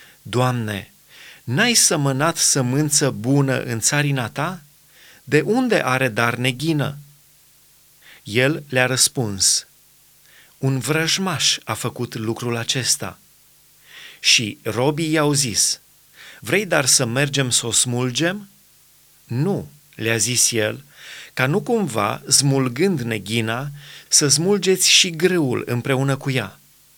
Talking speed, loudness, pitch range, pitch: 110 wpm, -18 LUFS, 120-155 Hz, 140 Hz